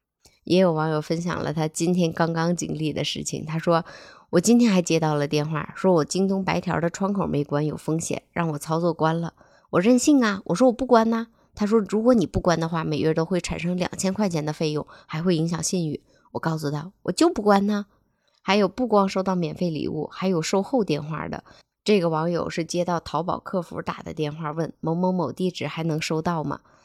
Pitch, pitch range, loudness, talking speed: 170 Hz, 160-195 Hz, -24 LUFS, 315 characters per minute